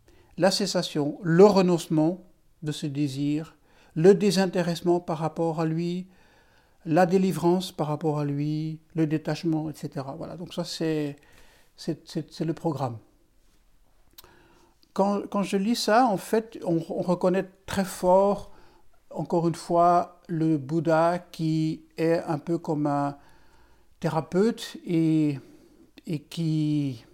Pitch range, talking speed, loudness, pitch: 155-185 Hz, 130 wpm, -26 LUFS, 165 Hz